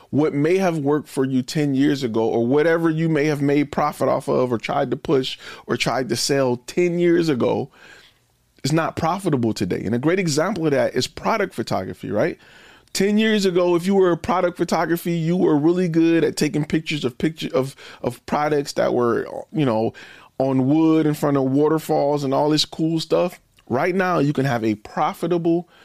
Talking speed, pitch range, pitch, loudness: 200 wpm, 135-170 Hz, 155 Hz, -20 LUFS